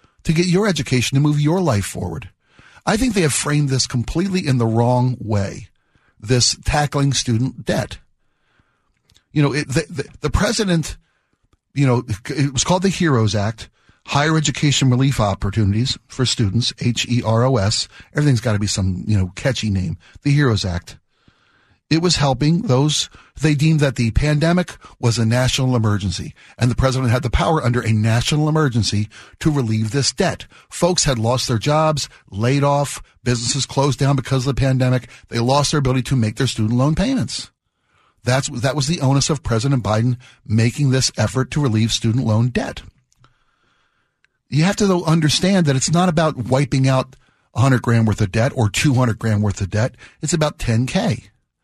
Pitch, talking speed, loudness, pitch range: 130 Hz, 180 wpm, -18 LUFS, 115-150 Hz